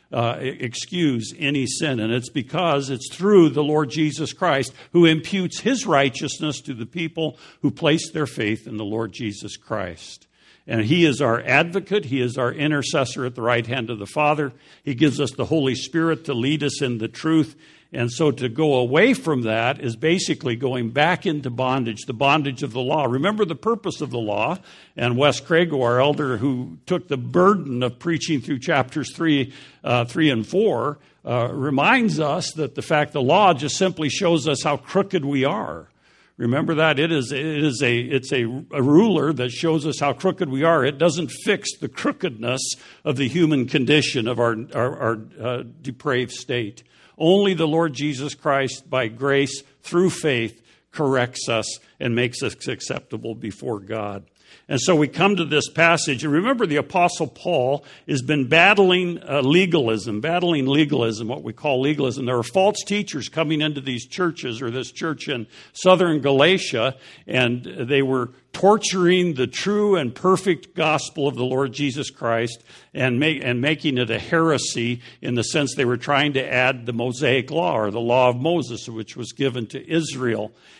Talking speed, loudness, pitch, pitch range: 180 wpm, -21 LUFS, 140 Hz, 125-160 Hz